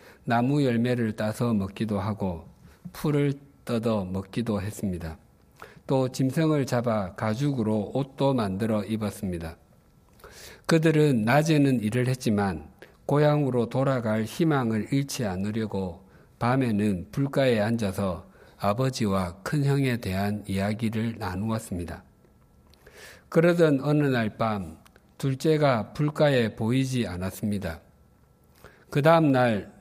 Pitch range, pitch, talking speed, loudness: 100-135 Hz, 115 Hz, 250 characters per minute, -26 LUFS